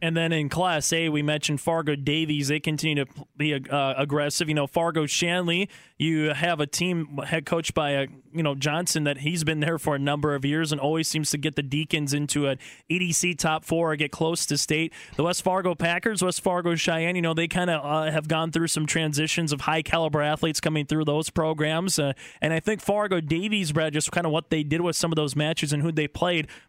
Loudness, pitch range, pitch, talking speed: -25 LUFS, 150-170 Hz, 155 Hz, 235 wpm